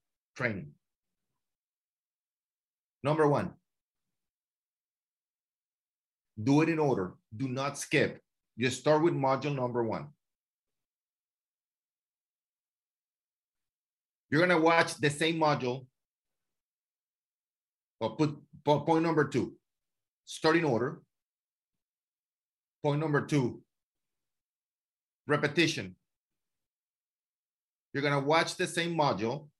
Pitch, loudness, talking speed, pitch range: 150 Hz, -30 LUFS, 80 wpm, 135-160 Hz